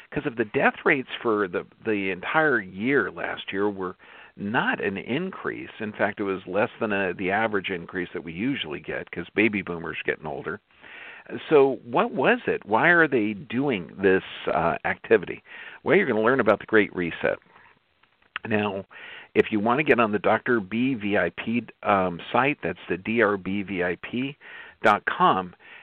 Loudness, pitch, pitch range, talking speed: -24 LUFS, 100 Hz, 95-110 Hz, 165 wpm